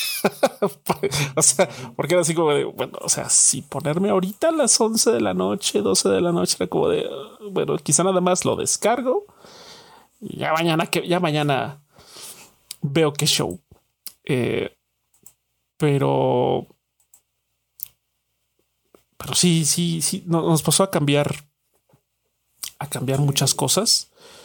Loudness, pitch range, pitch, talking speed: -20 LUFS, 140-200 Hz, 165 Hz, 135 wpm